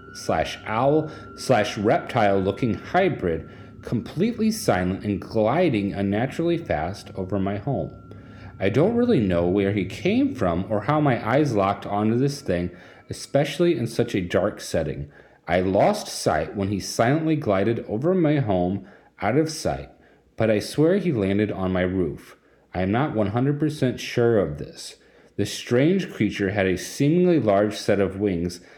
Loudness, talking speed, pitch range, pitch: -23 LUFS, 155 wpm, 95-145 Hz, 105 Hz